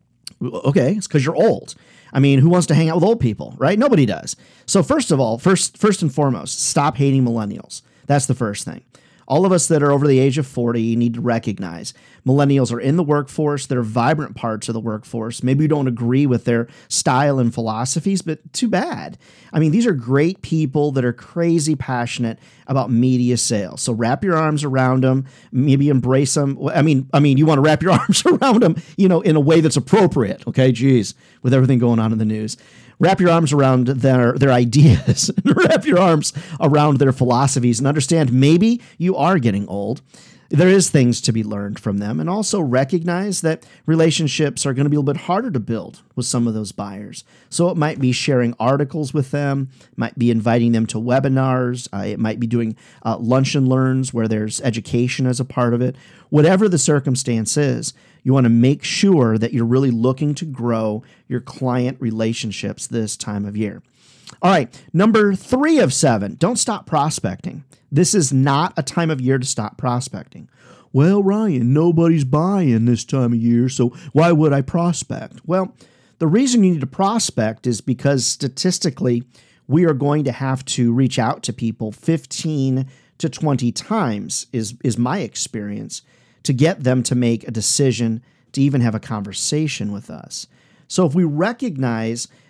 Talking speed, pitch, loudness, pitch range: 195 wpm, 135 Hz, -18 LUFS, 120-155 Hz